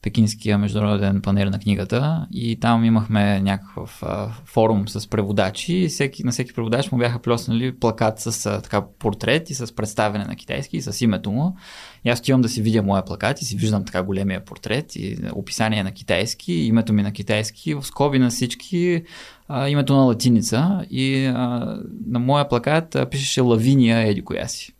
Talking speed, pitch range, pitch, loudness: 185 wpm, 105-135 Hz, 115 Hz, -21 LUFS